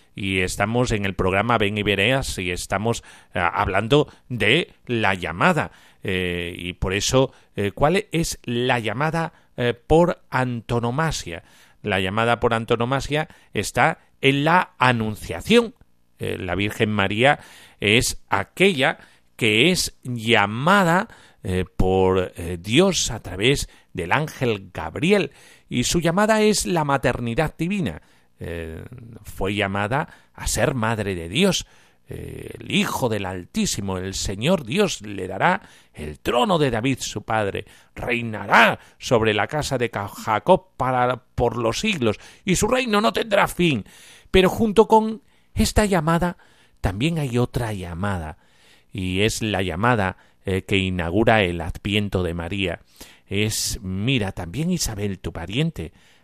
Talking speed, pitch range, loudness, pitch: 130 wpm, 95-145 Hz, -21 LUFS, 115 Hz